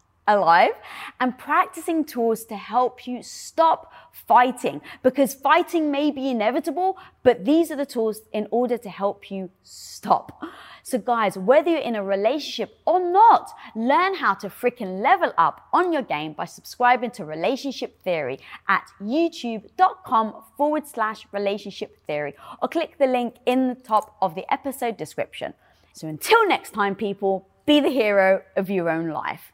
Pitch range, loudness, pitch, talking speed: 200-285 Hz, -22 LUFS, 240 Hz, 155 wpm